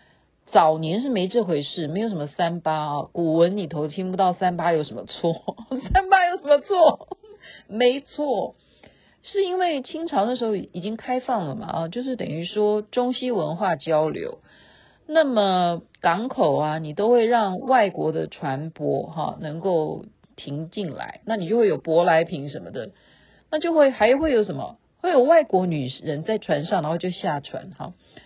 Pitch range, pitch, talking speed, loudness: 160-255 Hz, 200 Hz, 245 characters per minute, -23 LUFS